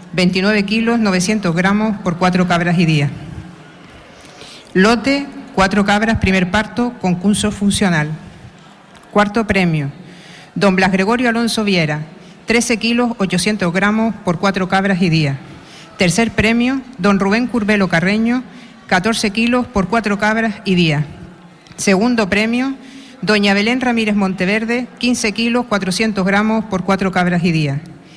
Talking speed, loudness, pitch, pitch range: 130 wpm, -15 LUFS, 200 Hz, 180-225 Hz